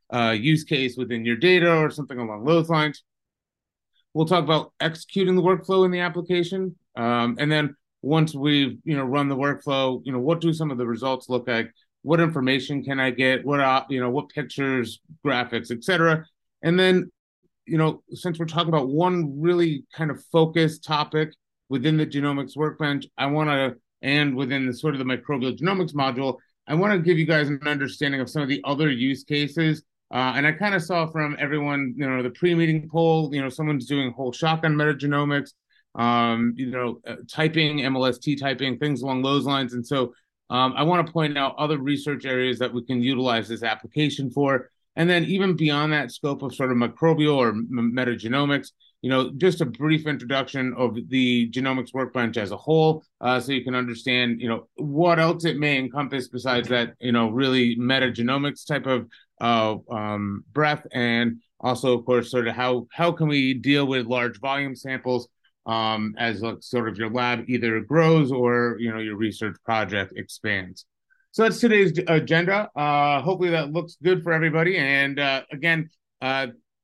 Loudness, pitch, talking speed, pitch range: -23 LUFS, 140 Hz, 190 wpm, 125-155 Hz